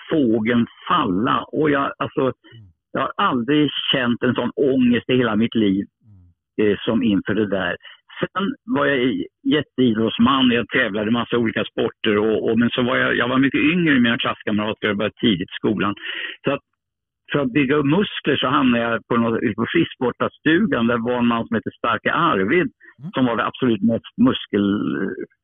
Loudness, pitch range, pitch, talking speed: -20 LUFS, 110-135 Hz, 120 Hz, 180 wpm